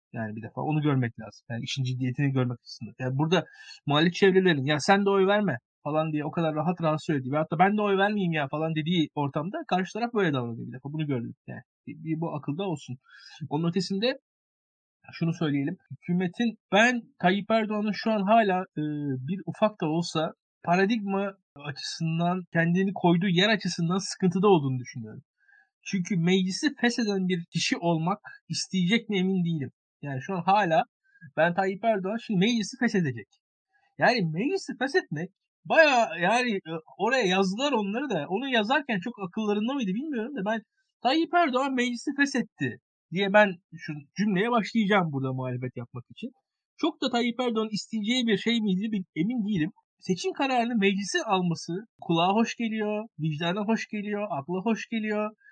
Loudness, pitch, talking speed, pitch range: -27 LUFS, 190 Hz, 160 wpm, 155-220 Hz